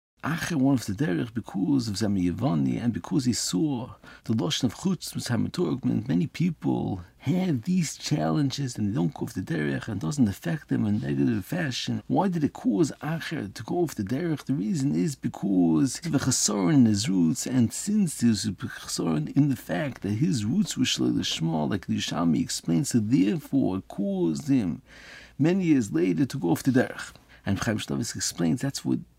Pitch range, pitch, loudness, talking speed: 95-150 Hz, 120 Hz, -26 LUFS, 185 wpm